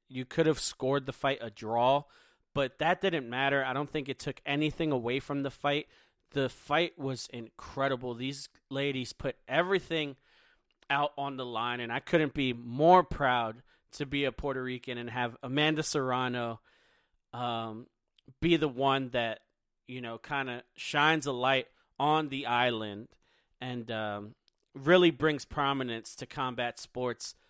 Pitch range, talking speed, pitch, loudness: 120-145 Hz, 155 wpm, 135 Hz, -31 LUFS